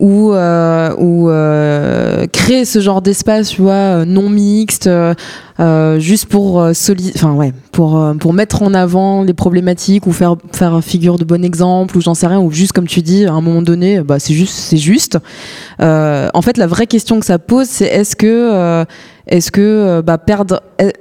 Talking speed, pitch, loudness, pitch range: 200 wpm, 180 Hz, -11 LUFS, 170-200 Hz